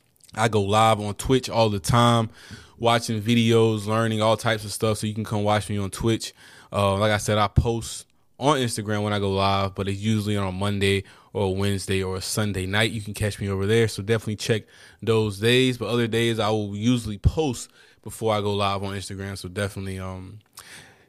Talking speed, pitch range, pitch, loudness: 215 wpm, 100-115 Hz, 105 Hz, -23 LUFS